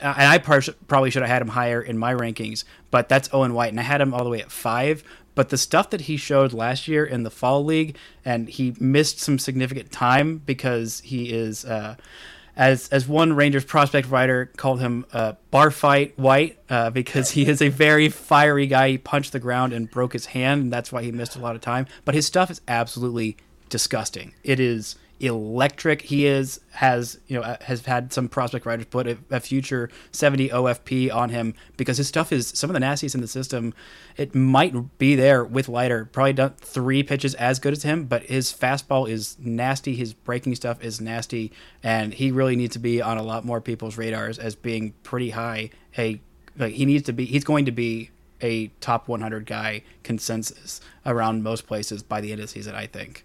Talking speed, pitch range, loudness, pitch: 215 wpm, 115-140 Hz, -22 LUFS, 125 Hz